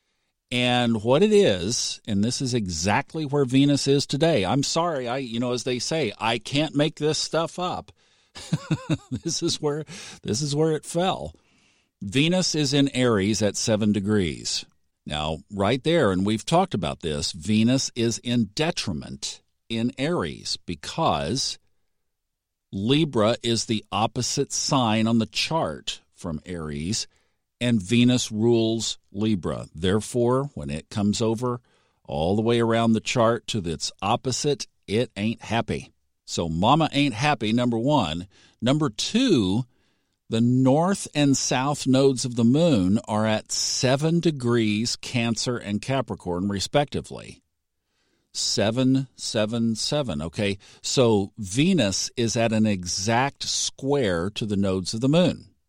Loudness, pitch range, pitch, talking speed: -24 LUFS, 105-140 Hz, 120 Hz, 140 wpm